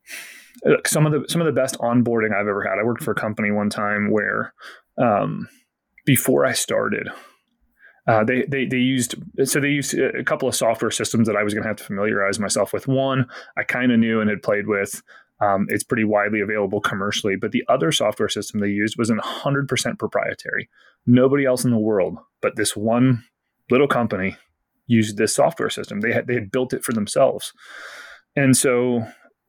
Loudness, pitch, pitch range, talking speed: -21 LUFS, 115 Hz, 105-130 Hz, 195 wpm